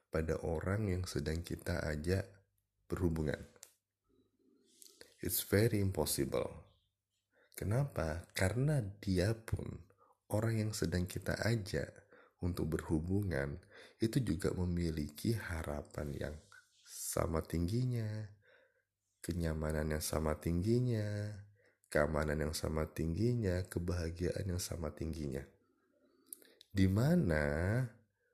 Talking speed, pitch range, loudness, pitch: 85 wpm, 80-105 Hz, -37 LUFS, 90 Hz